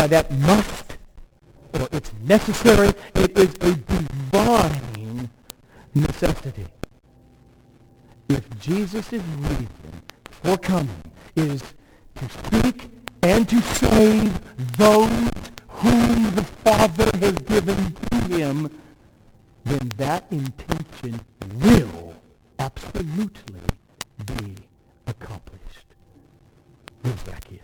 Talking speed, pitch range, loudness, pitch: 80 wpm, 115-190 Hz, -21 LUFS, 140 Hz